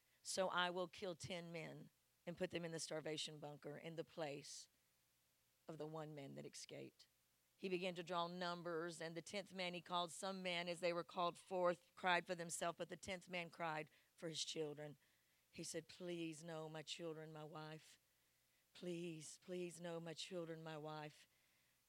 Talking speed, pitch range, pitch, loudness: 180 wpm, 155-175 Hz, 170 Hz, -48 LUFS